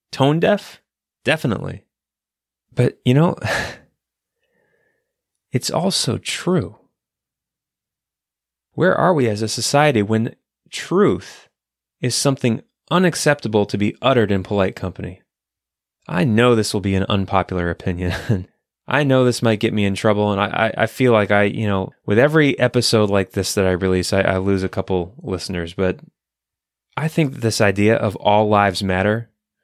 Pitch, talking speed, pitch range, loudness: 105 Hz, 150 wpm, 95-130 Hz, -18 LUFS